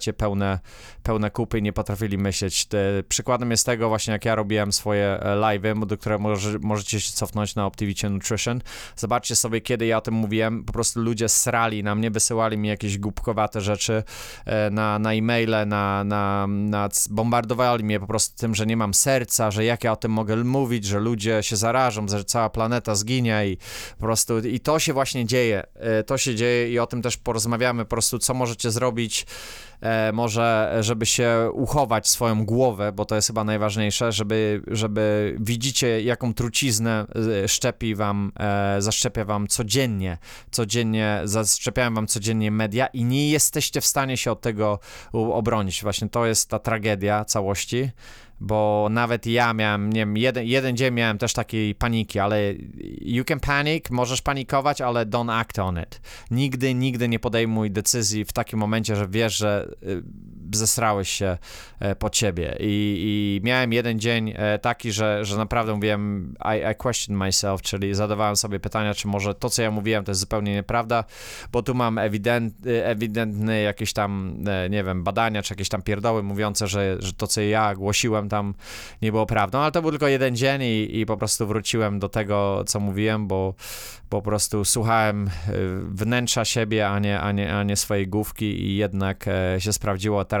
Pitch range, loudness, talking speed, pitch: 105-120 Hz, -23 LUFS, 175 wpm, 110 Hz